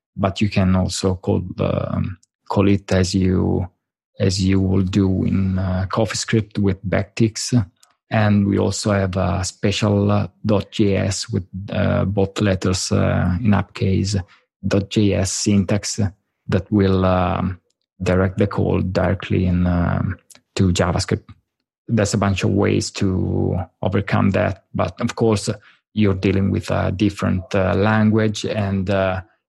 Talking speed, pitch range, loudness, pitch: 135 wpm, 95-105 Hz, -20 LUFS, 100 Hz